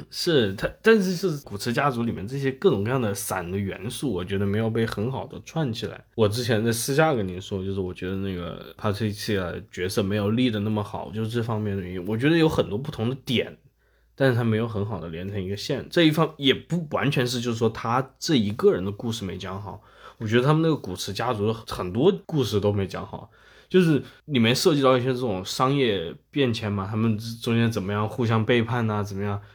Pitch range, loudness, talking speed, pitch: 100-130 Hz, -25 LUFS, 340 characters per minute, 115 Hz